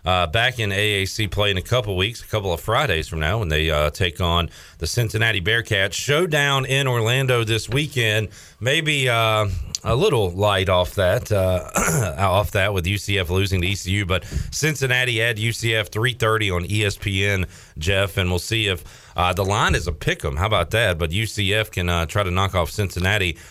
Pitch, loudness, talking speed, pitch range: 100 Hz, -20 LUFS, 190 wpm, 90-110 Hz